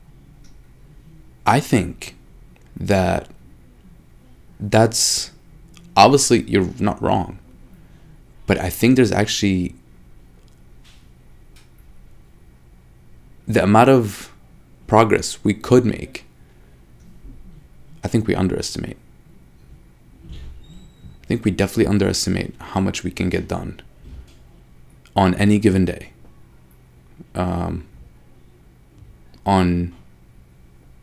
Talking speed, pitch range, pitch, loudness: 80 wpm, 65-100 Hz, 85 Hz, -18 LUFS